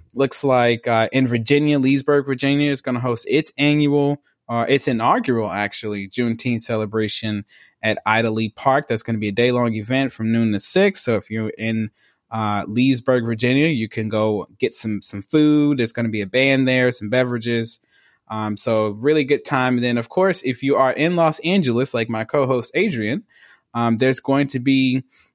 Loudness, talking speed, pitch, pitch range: -19 LUFS, 195 wpm, 125 Hz, 110-135 Hz